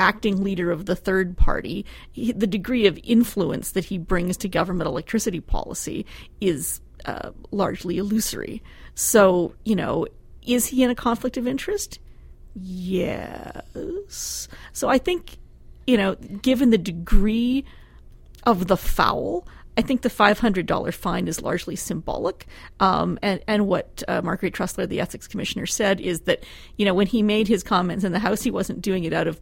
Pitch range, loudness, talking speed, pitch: 185-235 Hz, -23 LUFS, 165 wpm, 205 Hz